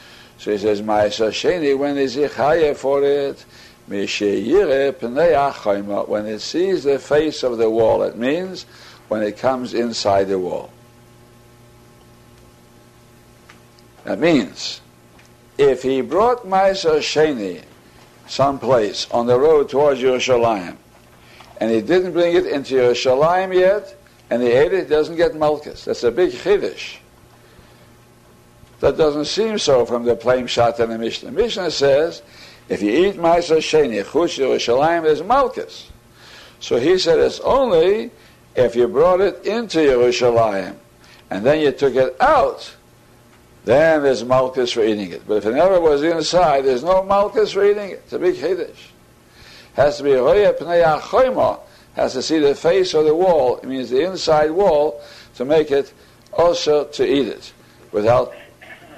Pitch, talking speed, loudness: 145 Hz, 145 wpm, -17 LUFS